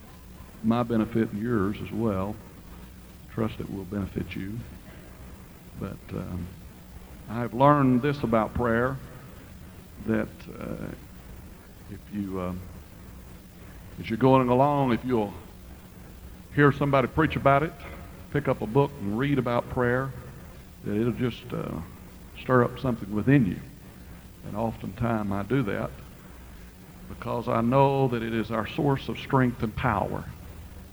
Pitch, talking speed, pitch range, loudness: 110 Hz, 130 wpm, 95-125 Hz, -26 LUFS